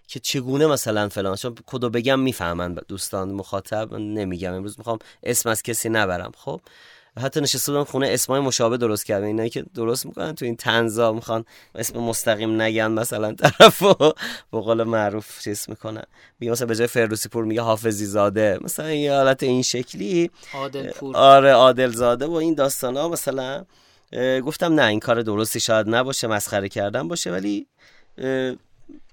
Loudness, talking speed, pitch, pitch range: -21 LUFS, 165 wpm, 115 Hz, 110-135 Hz